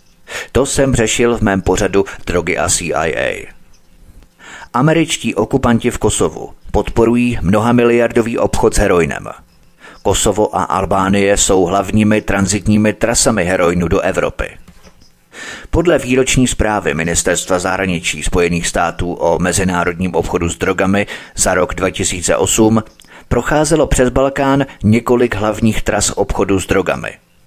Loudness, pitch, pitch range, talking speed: -14 LUFS, 105 Hz, 95-120 Hz, 115 wpm